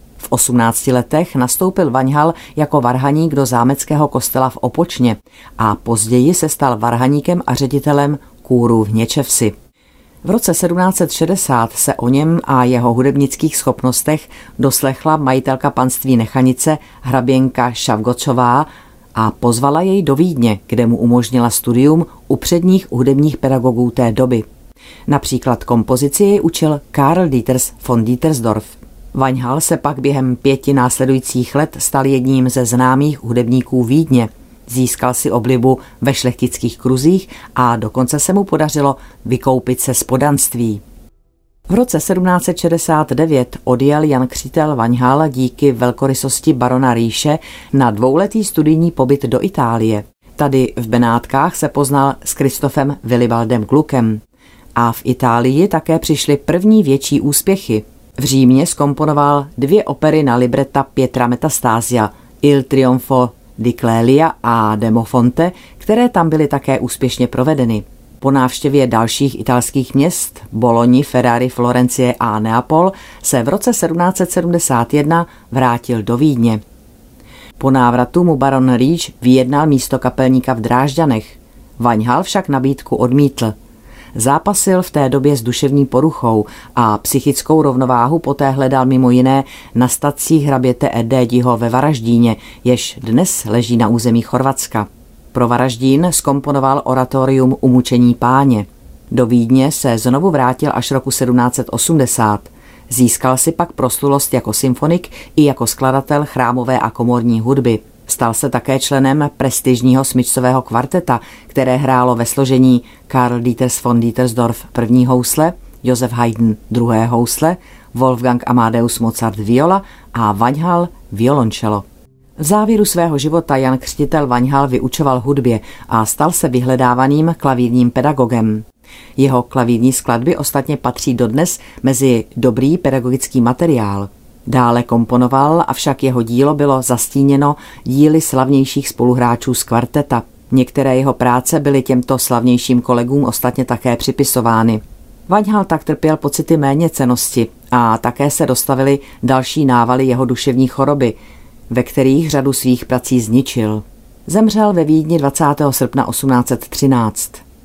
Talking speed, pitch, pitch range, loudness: 125 wpm, 130 Hz, 120-145 Hz, -13 LUFS